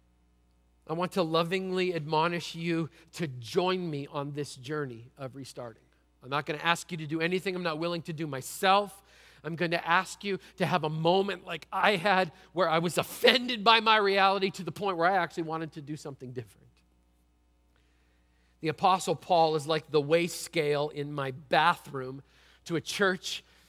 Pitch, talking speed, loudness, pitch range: 160 Hz, 185 wpm, -29 LUFS, 135-180 Hz